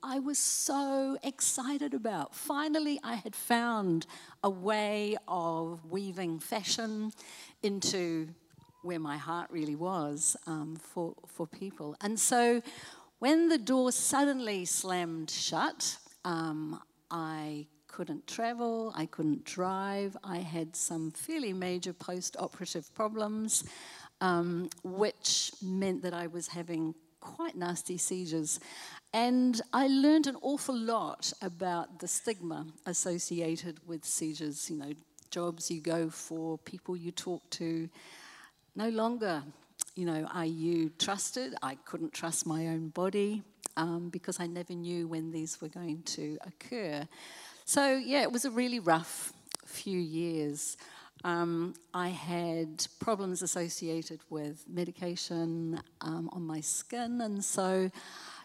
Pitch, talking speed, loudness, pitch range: 175 Hz, 130 wpm, -34 LUFS, 160-215 Hz